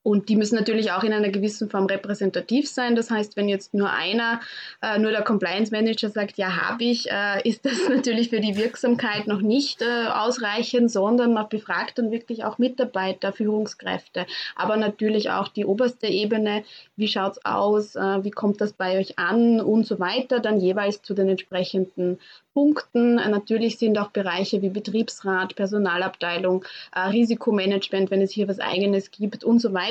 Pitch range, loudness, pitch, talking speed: 195-230 Hz, -23 LUFS, 210 Hz, 170 wpm